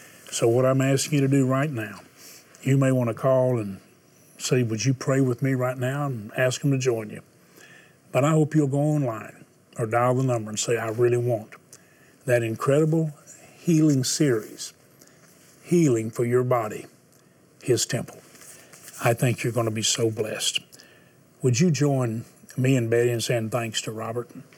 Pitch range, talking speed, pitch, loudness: 115-140 Hz, 180 wpm, 125 Hz, -24 LUFS